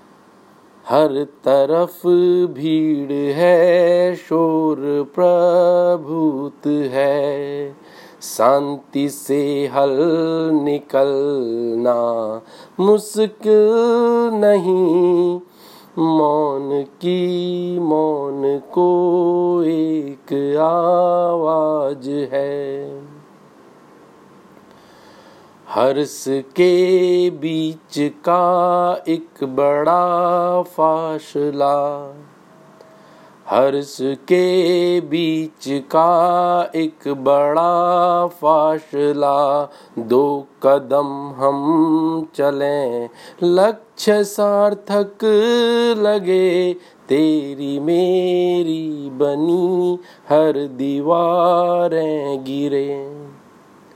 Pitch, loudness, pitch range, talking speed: 160 Hz, -17 LUFS, 140-175 Hz, 50 wpm